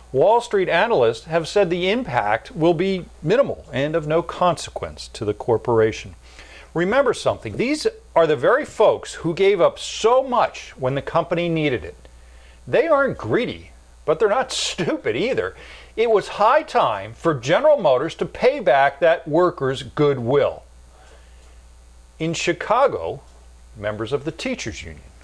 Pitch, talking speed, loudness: 160 Hz, 145 wpm, -20 LUFS